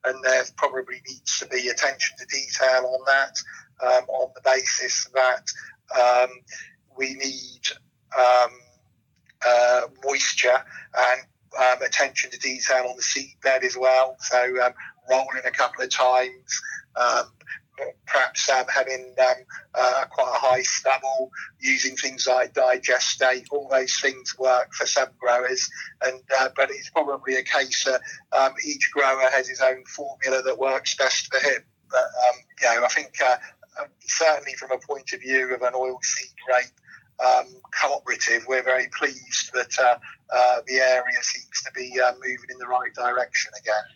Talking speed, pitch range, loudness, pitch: 160 wpm, 125-130 Hz, -23 LUFS, 130 Hz